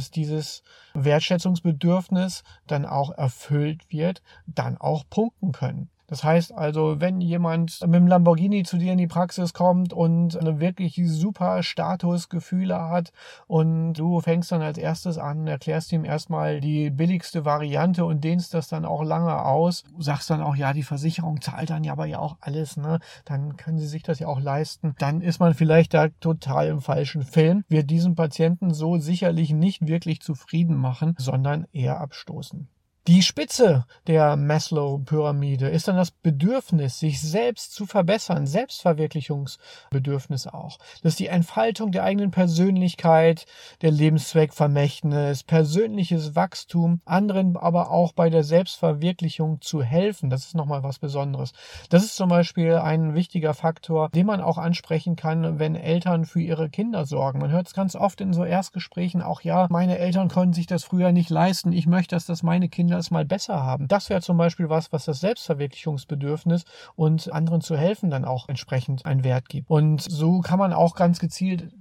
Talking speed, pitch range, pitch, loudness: 170 wpm, 155-175 Hz, 165 Hz, -23 LUFS